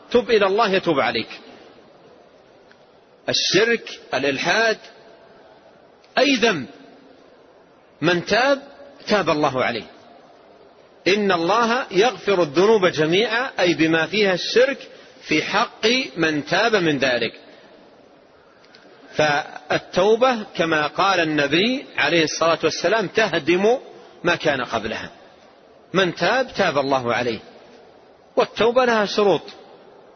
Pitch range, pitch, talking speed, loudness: 160-230 Hz, 180 Hz, 95 wpm, -19 LUFS